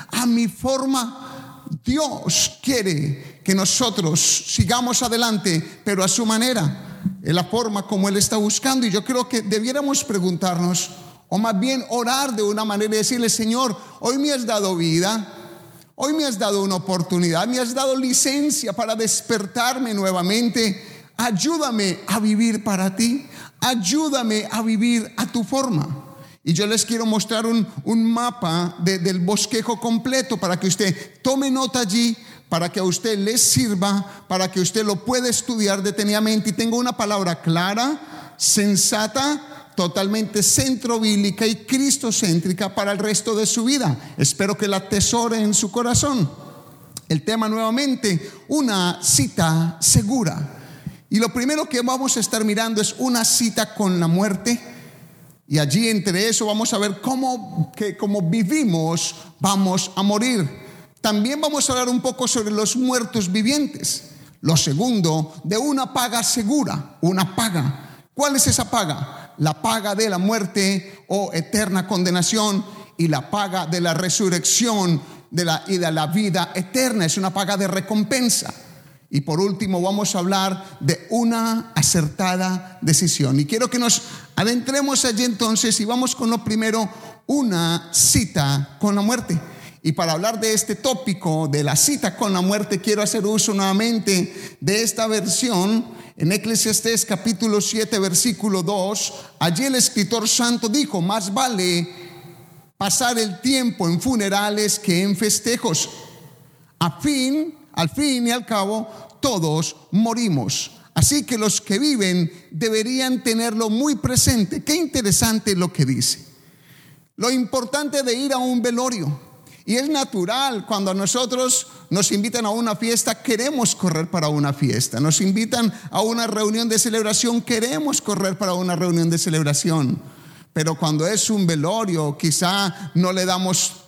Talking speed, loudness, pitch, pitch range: 150 wpm, -20 LUFS, 210 Hz, 175-235 Hz